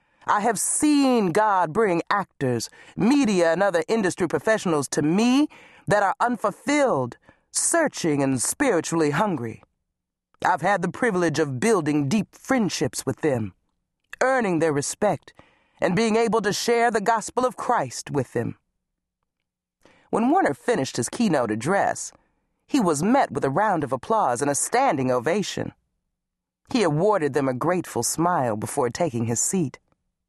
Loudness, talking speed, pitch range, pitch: -23 LUFS, 145 wpm, 145-225 Hz, 175 Hz